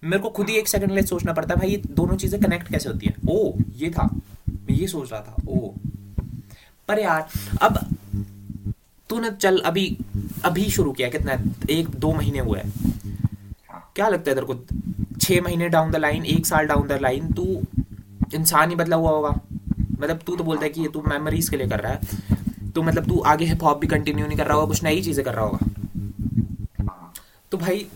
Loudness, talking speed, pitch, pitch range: -23 LUFS, 130 wpm, 135 Hz, 105-165 Hz